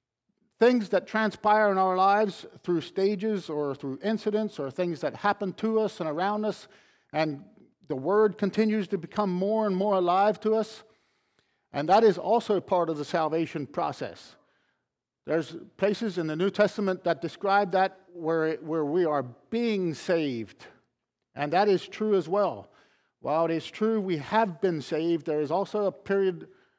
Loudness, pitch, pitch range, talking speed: -27 LUFS, 190 Hz, 165-210 Hz, 170 wpm